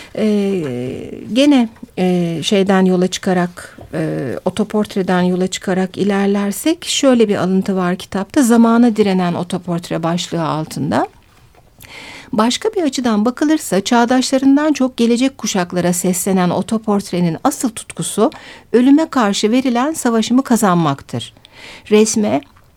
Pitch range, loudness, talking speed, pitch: 180-240 Hz, -15 LUFS, 105 wpm, 205 Hz